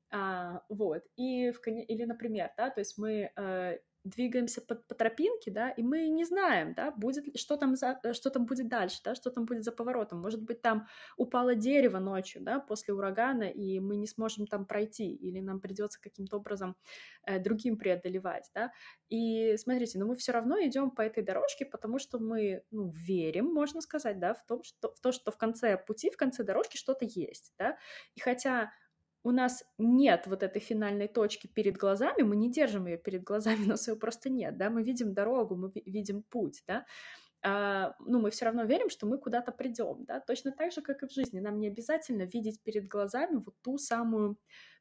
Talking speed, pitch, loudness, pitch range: 200 wpm, 225 Hz, -34 LUFS, 205-250 Hz